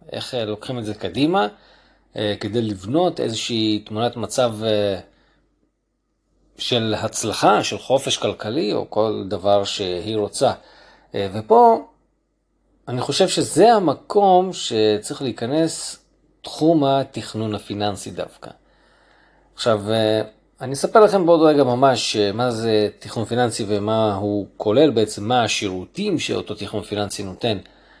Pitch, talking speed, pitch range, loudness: 110 Hz, 110 wpm, 105-130 Hz, -20 LUFS